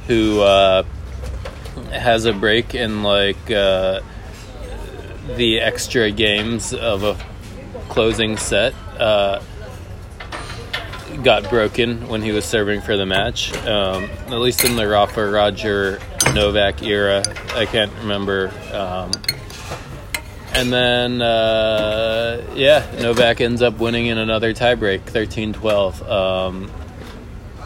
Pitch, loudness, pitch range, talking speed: 105 Hz, -18 LUFS, 95-115 Hz, 115 wpm